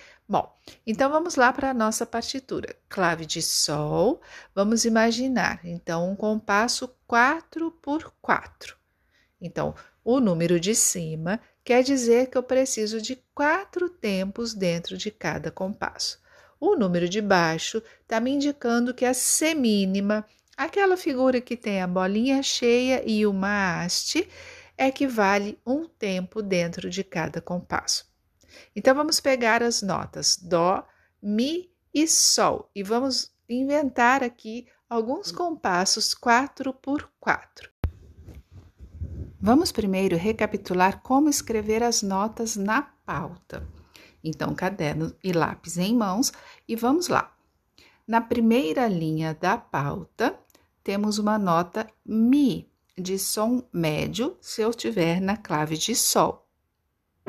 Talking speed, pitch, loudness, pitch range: 125 wpm, 225 Hz, -24 LUFS, 185-260 Hz